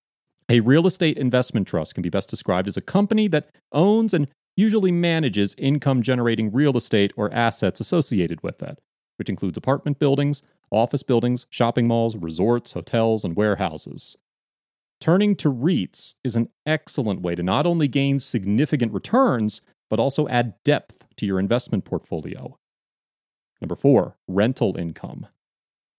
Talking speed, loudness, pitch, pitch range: 145 wpm, -22 LUFS, 125 Hz, 110-150 Hz